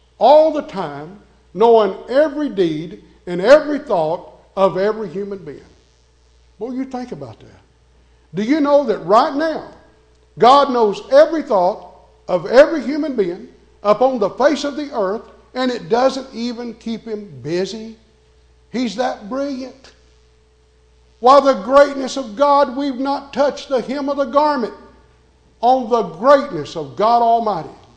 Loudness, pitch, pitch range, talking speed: -16 LUFS, 230 Hz, 175-275 Hz, 145 wpm